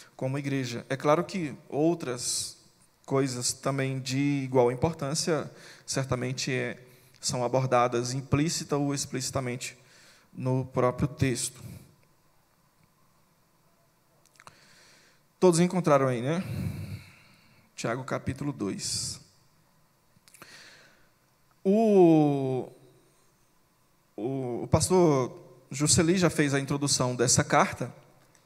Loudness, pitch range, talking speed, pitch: -27 LUFS, 130-165 Hz, 80 wpm, 140 Hz